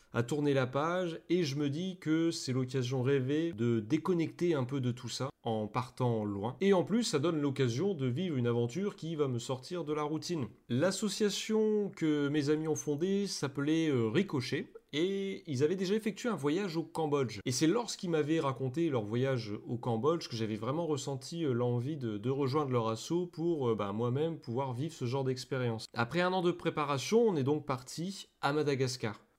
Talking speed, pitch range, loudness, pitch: 190 wpm, 125-170 Hz, -33 LUFS, 150 Hz